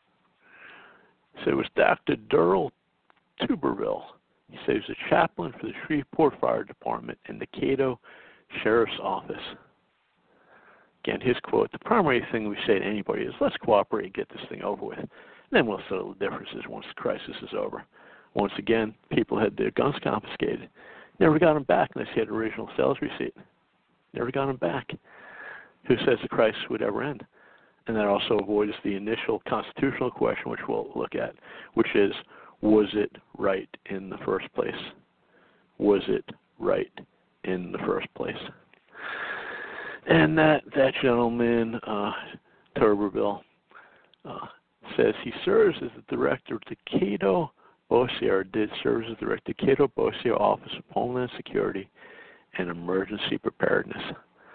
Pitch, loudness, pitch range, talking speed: 115 Hz, -27 LUFS, 105-135 Hz, 155 wpm